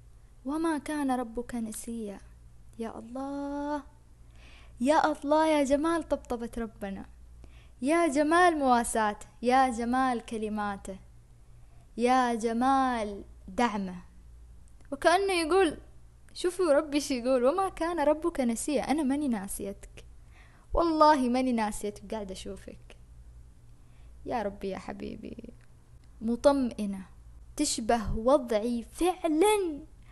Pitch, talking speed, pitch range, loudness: 245 Hz, 95 wpm, 200-290 Hz, -28 LUFS